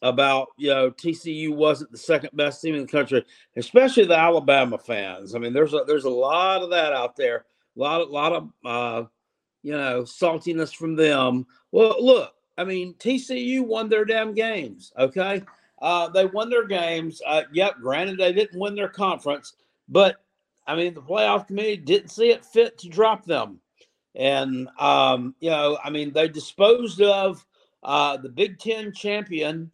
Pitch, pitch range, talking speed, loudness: 170 Hz, 145-210 Hz, 180 wpm, -22 LUFS